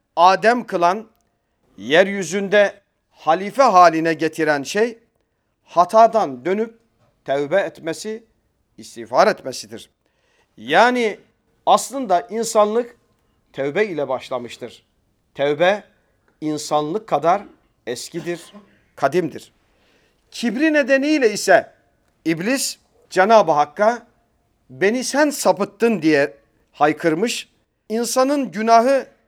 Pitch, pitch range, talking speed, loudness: 185 Hz, 145-230 Hz, 75 wpm, -18 LUFS